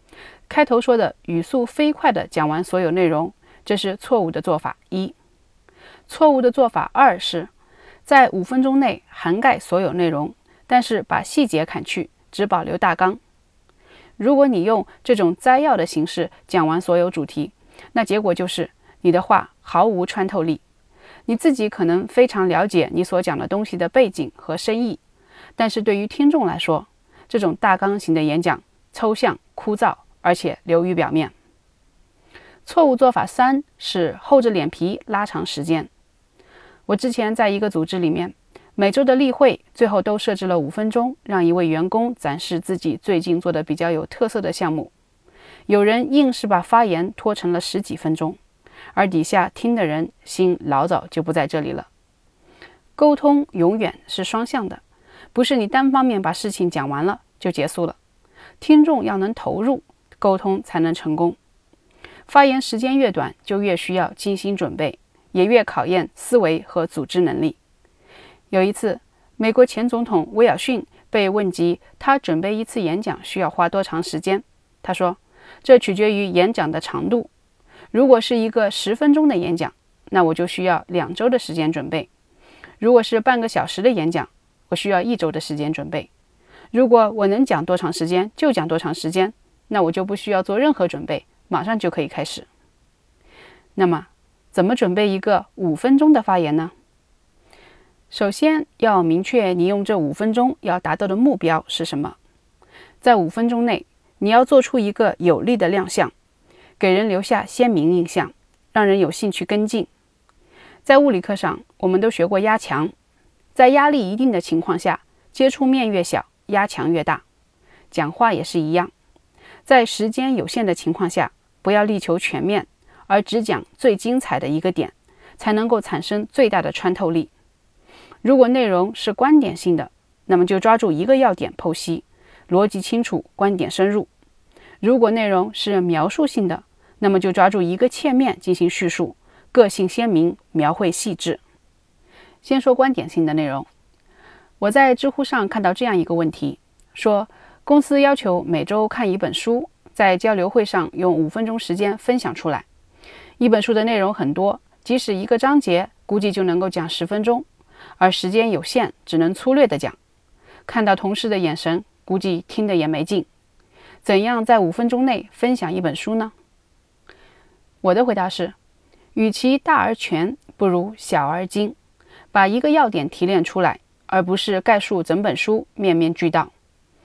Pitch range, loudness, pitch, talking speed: 175-235 Hz, -19 LUFS, 195 Hz, 250 characters per minute